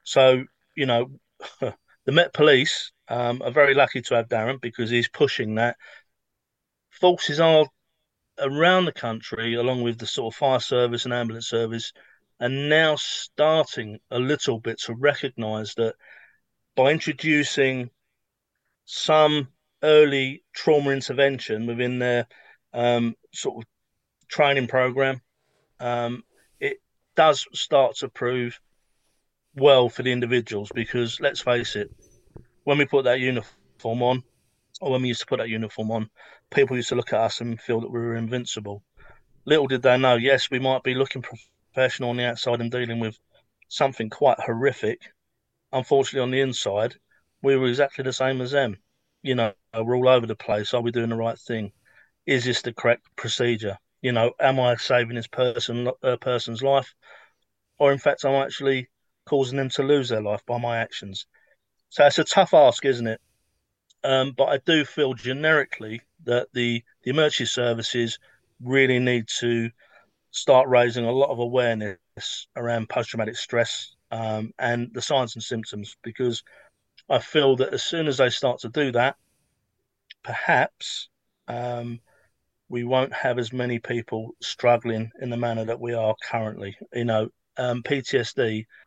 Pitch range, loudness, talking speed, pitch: 115-135 Hz, -23 LUFS, 160 wpm, 120 Hz